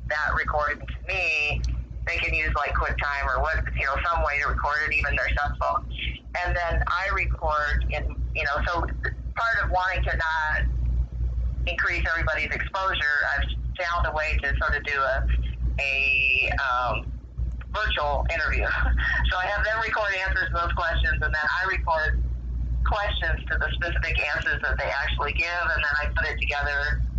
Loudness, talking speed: -25 LUFS, 175 wpm